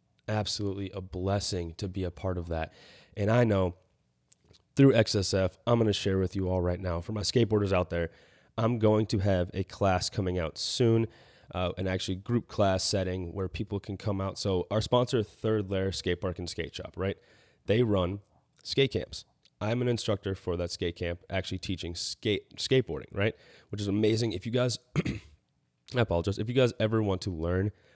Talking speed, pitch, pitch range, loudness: 190 wpm, 95 Hz, 90-110 Hz, -30 LUFS